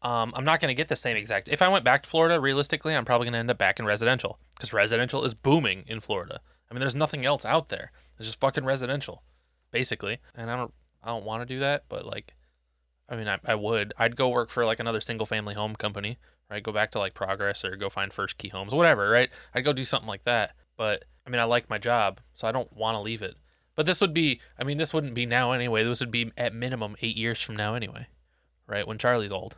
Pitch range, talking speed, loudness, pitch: 105-135 Hz, 260 wpm, -27 LUFS, 115 Hz